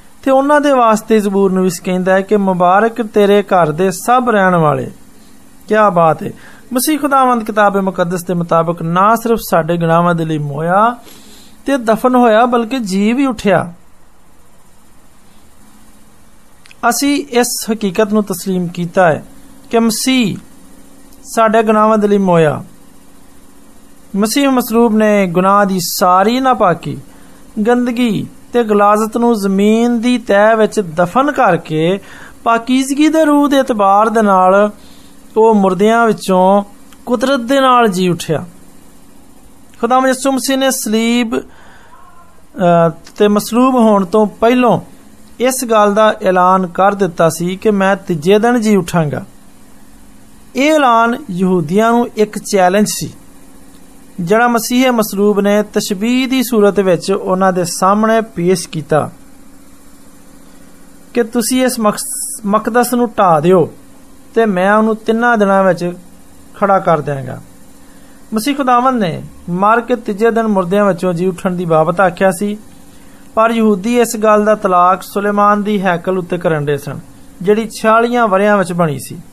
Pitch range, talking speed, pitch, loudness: 185-245 Hz, 130 wpm, 215 Hz, -12 LUFS